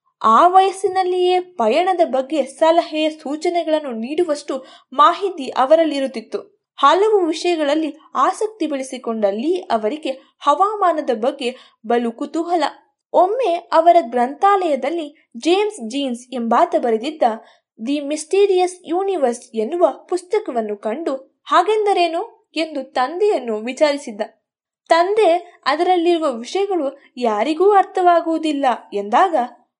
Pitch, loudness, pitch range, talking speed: 310 Hz, -18 LUFS, 260-360 Hz, 85 wpm